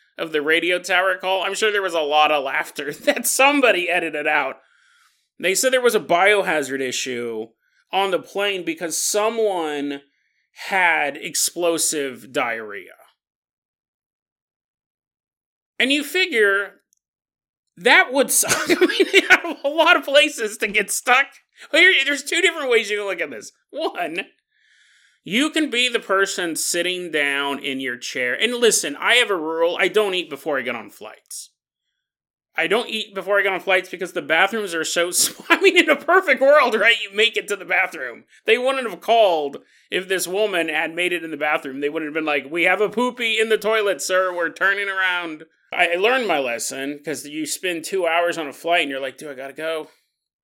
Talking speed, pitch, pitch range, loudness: 190 wpm, 190 Hz, 160-240 Hz, -19 LUFS